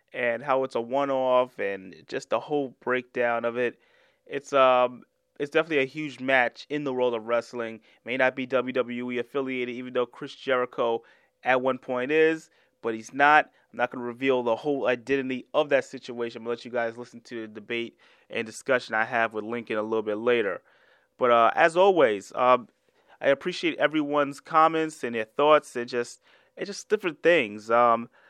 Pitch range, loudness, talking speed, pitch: 120-140 Hz, -26 LUFS, 185 wpm, 125 Hz